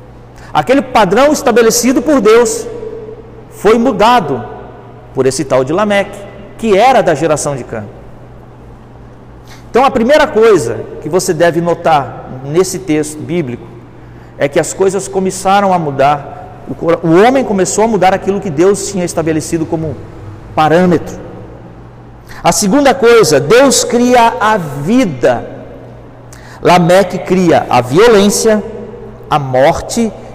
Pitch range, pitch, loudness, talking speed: 145-220 Hz, 185 Hz, -10 LUFS, 120 wpm